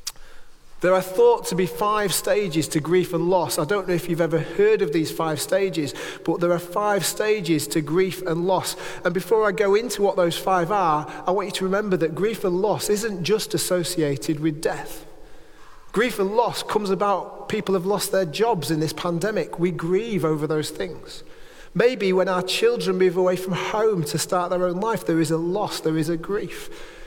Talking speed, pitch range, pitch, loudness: 205 wpm, 170-205 Hz, 185 Hz, -22 LUFS